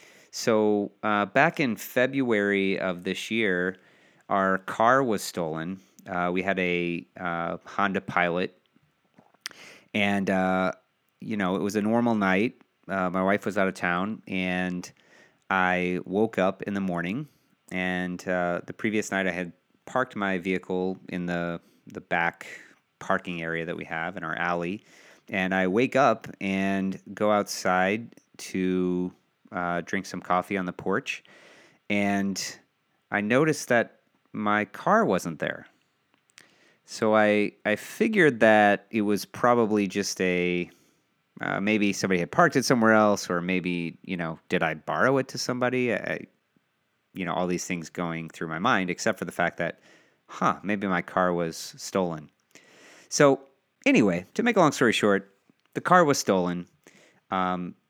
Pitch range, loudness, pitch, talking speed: 90-105 Hz, -26 LUFS, 95 Hz, 155 wpm